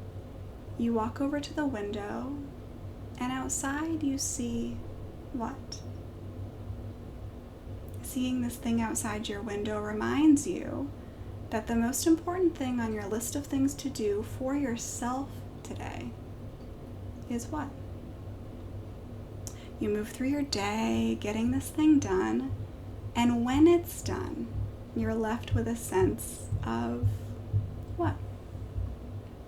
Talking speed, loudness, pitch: 115 wpm, -31 LUFS, 115 Hz